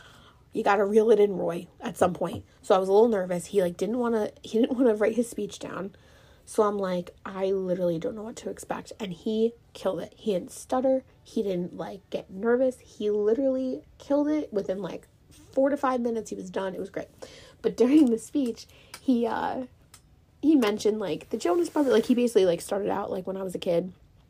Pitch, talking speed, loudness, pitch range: 220 Hz, 225 wpm, -27 LUFS, 195-255 Hz